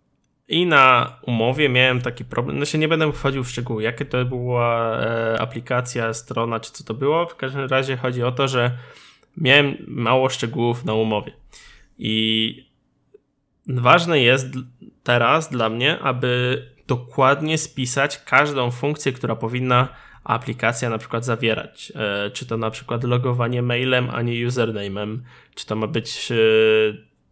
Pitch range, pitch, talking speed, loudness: 115-135 Hz, 125 Hz, 145 wpm, -20 LUFS